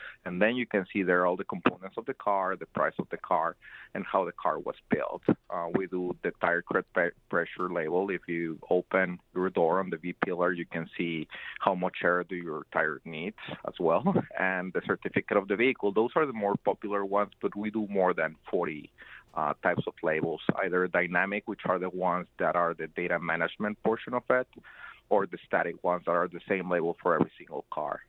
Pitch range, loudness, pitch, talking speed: 85-100 Hz, -30 LUFS, 90 Hz, 215 wpm